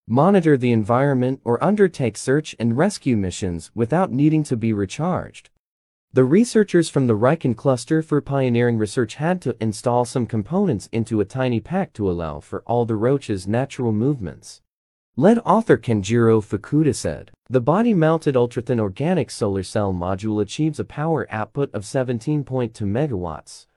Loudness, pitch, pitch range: -20 LUFS, 125 Hz, 110-150 Hz